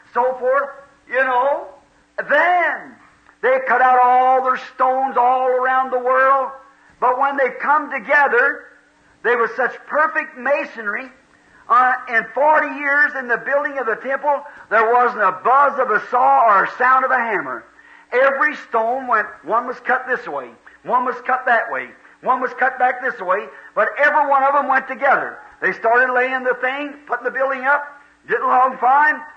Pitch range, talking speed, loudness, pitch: 250-285 Hz, 175 wpm, -17 LUFS, 260 Hz